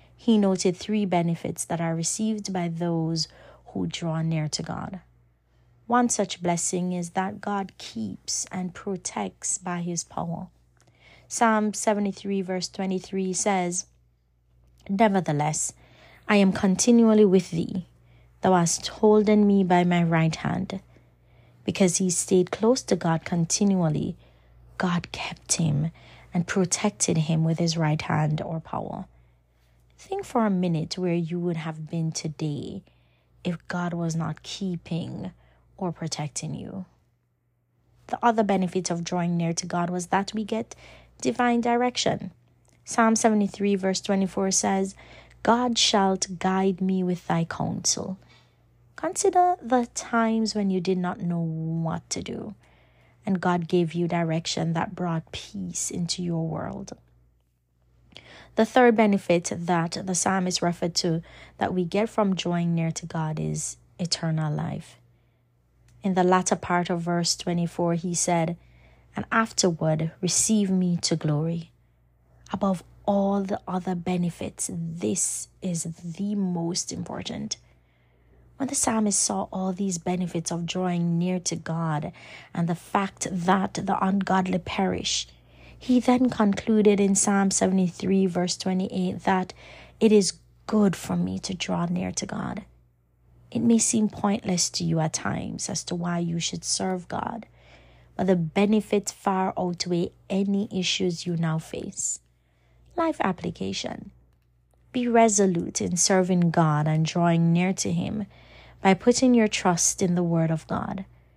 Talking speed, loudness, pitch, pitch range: 140 wpm, -25 LUFS, 175 Hz, 160-195 Hz